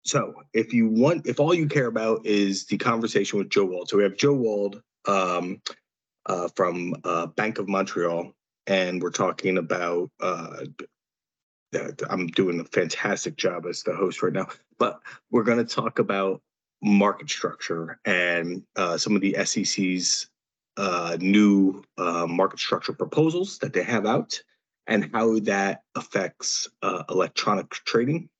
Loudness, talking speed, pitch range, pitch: -25 LUFS, 155 wpm, 90-115 Hz, 100 Hz